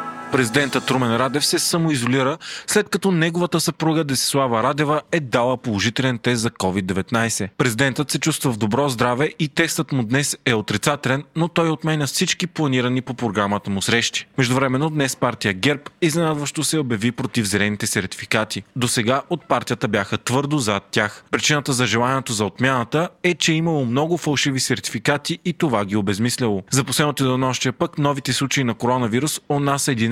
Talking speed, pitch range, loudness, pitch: 165 wpm, 120-150 Hz, -20 LUFS, 135 Hz